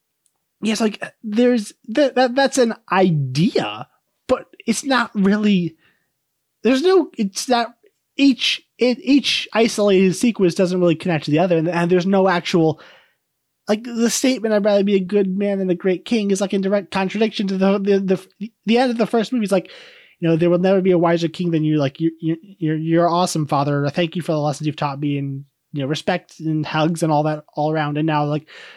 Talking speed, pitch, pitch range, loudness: 210 wpm, 190 Hz, 160-220 Hz, -19 LUFS